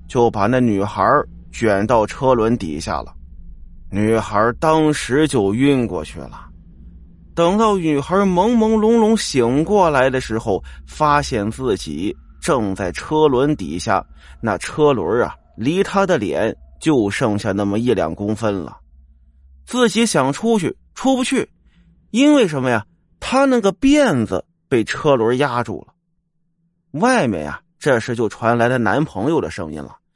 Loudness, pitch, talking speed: -18 LUFS, 125 Hz, 205 characters per minute